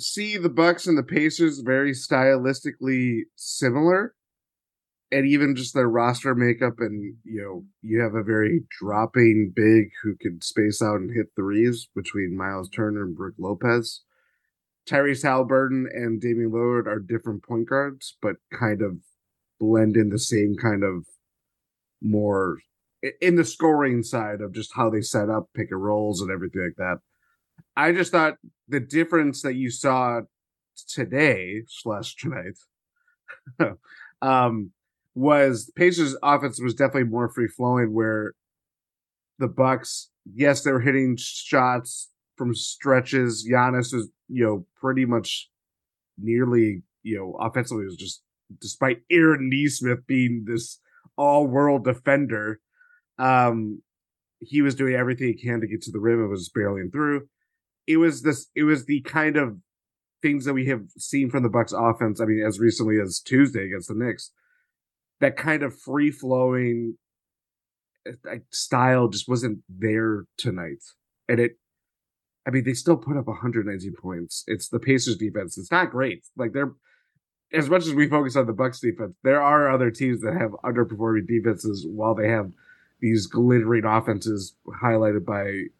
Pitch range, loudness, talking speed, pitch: 110-135 Hz, -23 LUFS, 155 wpm, 120 Hz